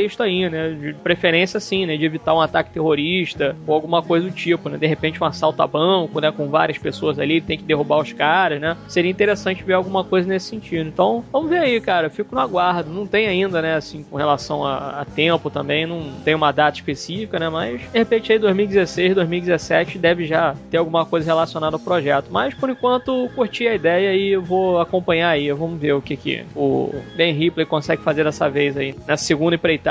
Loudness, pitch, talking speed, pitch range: -19 LUFS, 165 Hz, 220 wpm, 155-185 Hz